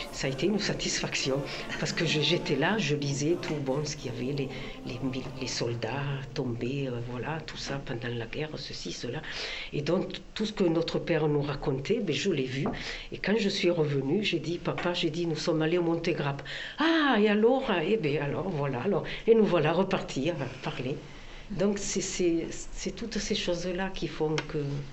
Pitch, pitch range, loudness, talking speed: 160 Hz, 140-180 Hz, -30 LUFS, 200 wpm